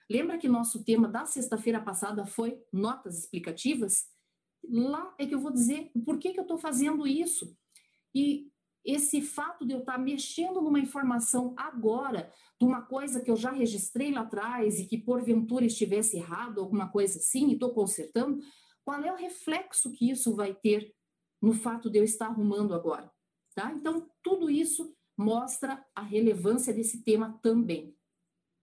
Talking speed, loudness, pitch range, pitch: 165 wpm, -30 LUFS, 215-280 Hz, 240 Hz